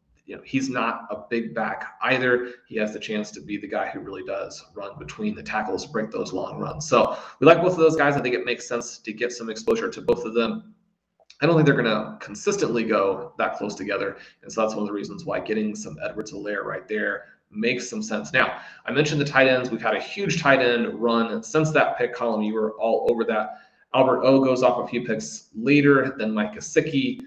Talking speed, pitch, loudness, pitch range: 235 wpm, 125 Hz, -23 LUFS, 115-155 Hz